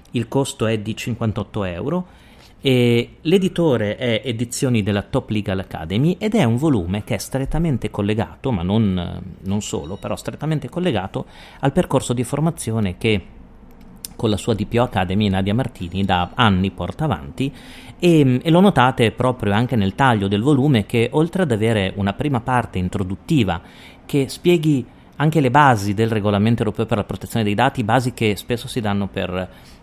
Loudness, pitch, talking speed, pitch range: -20 LUFS, 115 Hz, 165 wpm, 100-135 Hz